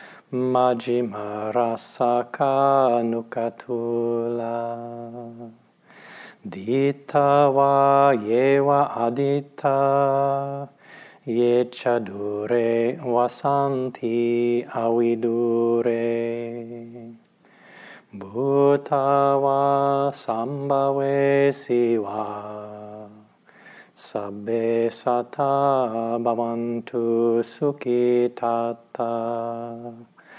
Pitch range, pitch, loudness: 115-140 Hz, 120 Hz, -22 LUFS